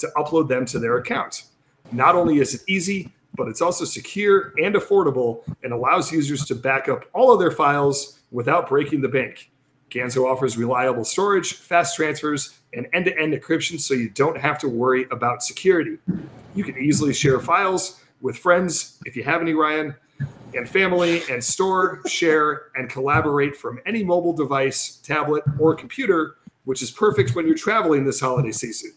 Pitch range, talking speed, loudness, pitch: 130-175 Hz, 175 wpm, -21 LUFS, 150 Hz